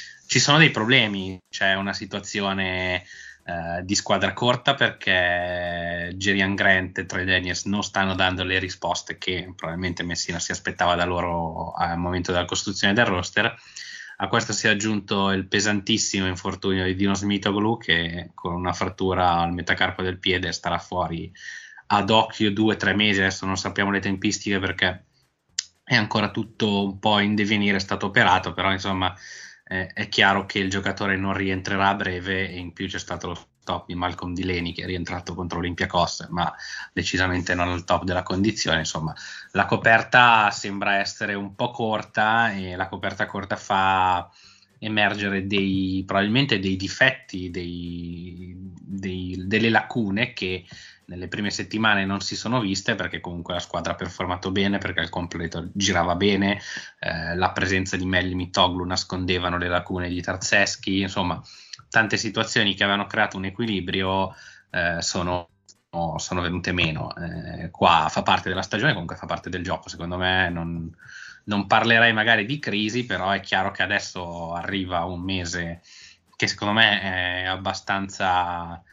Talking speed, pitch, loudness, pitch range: 160 wpm, 95 Hz, -23 LUFS, 90-100 Hz